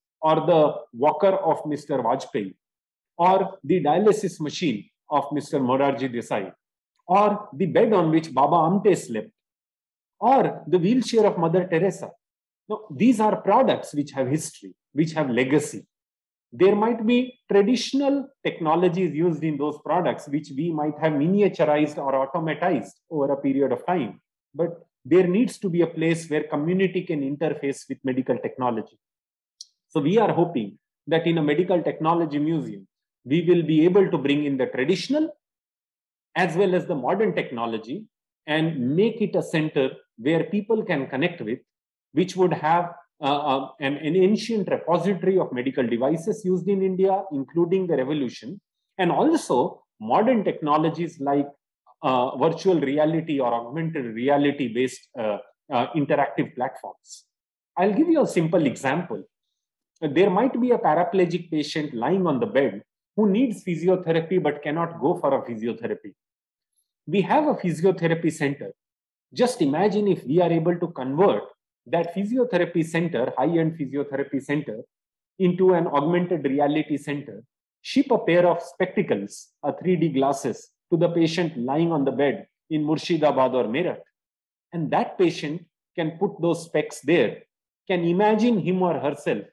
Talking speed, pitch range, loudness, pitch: 150 wpm, 145-190 Hz, -23 LUFS, 165 Hz